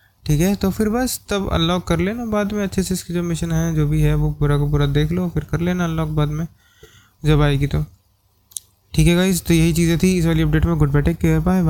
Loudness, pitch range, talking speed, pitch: -19 LUFS, 150-180 Hz, 255 wpm, 165 Hz